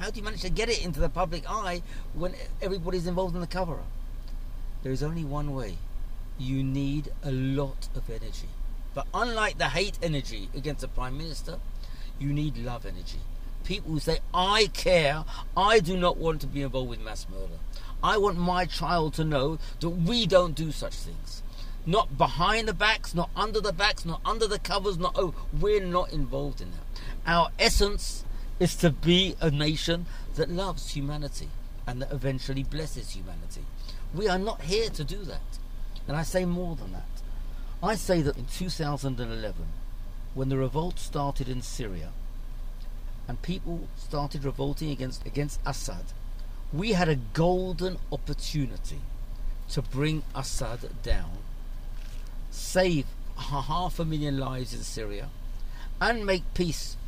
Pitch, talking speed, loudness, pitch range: 140 Hz, 160 wpm, -29 LUFS, 115-175 Hz